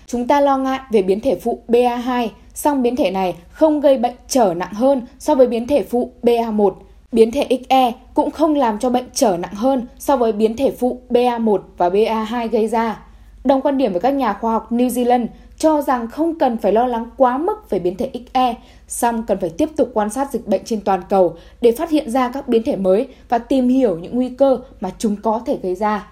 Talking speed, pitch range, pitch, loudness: 230 wpm, 220-265 Hz, 245 Hz, -18 LUFS